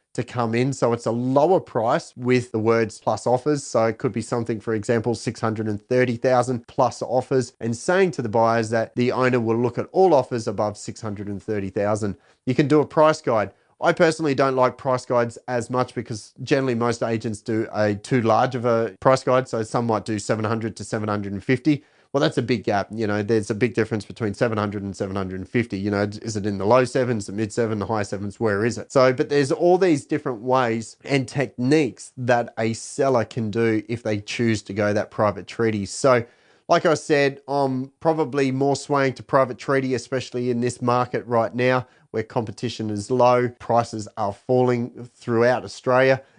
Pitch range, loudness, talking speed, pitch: 110-130 Hz, -22 LUFS, 195 wpm, 120 Hz